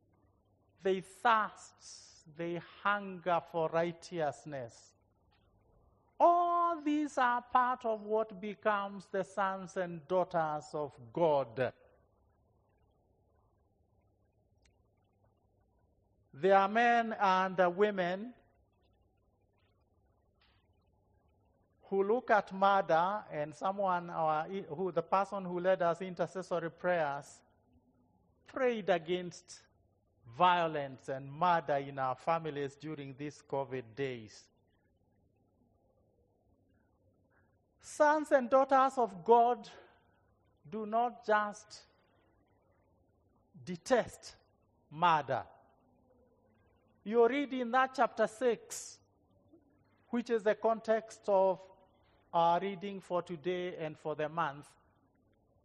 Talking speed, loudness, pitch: 85 wpm, -33 LUFS, 160 Hz